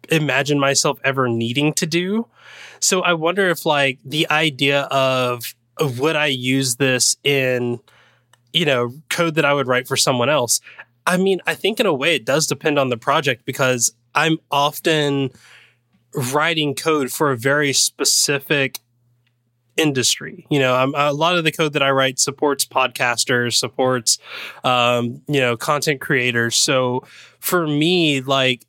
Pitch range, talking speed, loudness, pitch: 125-155 Hz, 160 wpm, -18 LUFS, 140 Hz